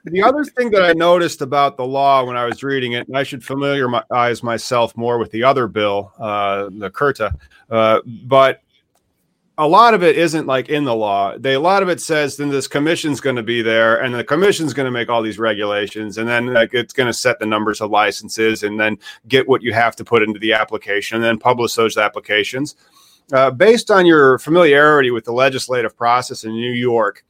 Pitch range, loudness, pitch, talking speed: 110-140 Hz, -16 LUFS, 120 Hz, 220 wpm